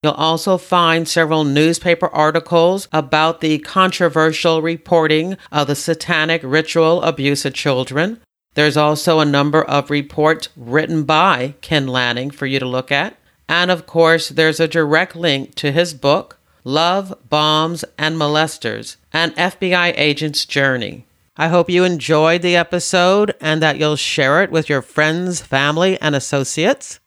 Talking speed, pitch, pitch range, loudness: 150 wpm, 160 Hz, 150-170 Hz, -16 LUFS